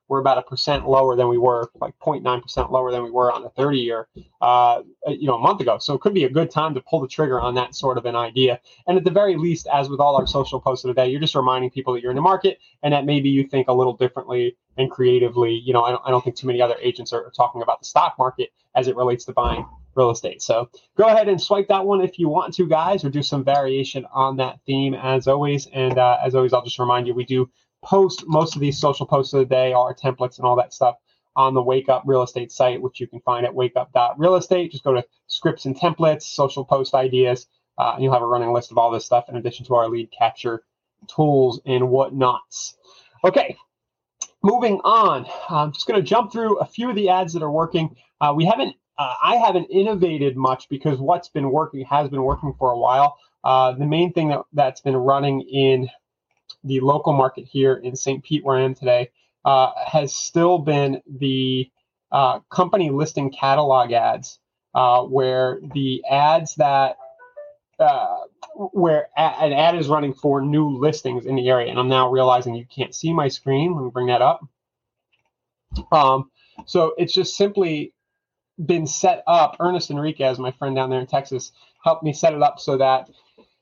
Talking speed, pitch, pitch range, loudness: 220 wpm, 135 Hz, 125-155 Hz, -20 LUFS